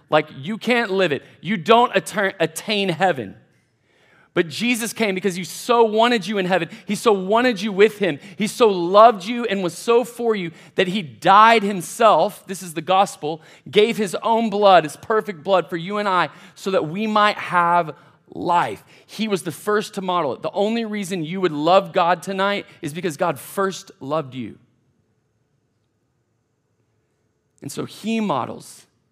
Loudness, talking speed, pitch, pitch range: -19 LUFS, 175 wpm, 190 Hz, 165-215 Hz